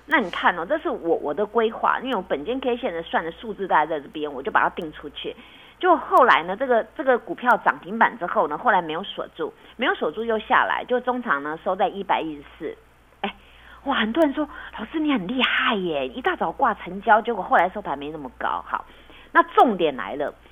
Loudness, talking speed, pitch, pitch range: -23 LUFS, 320 characters per minute, 230 Hz, 185-275 Hz